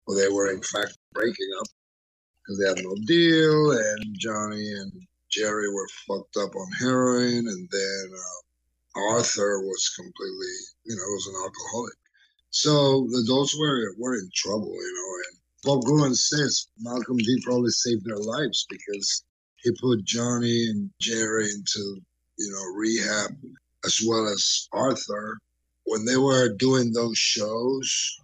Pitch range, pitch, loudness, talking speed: 100-130 Hz, 110 Hz, -25 LUFS, 150 wpm